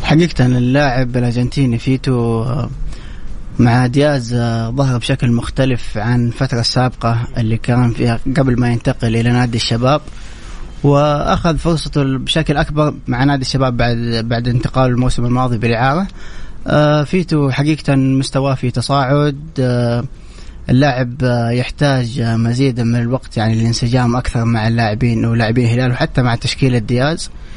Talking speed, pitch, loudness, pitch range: 120 wpm, 125 Hz, -15 LUFS, 120-140 Hz